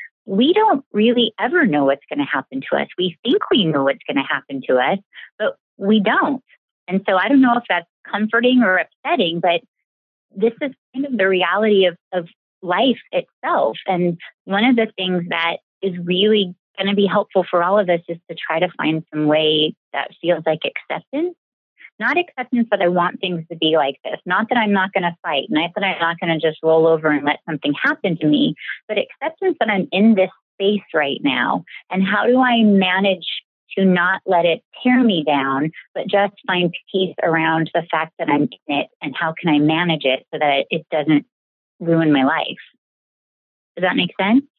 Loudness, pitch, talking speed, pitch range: -18 LUFS, 185 Hz, 205 wpm, 160-215 Hz